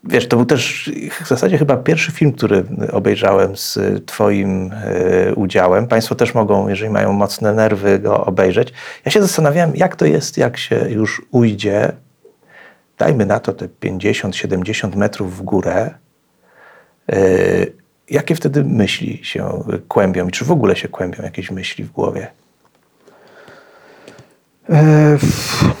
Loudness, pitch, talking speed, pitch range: -15 LUFS, 120 Hz, 135 wpm, 105-150 Hz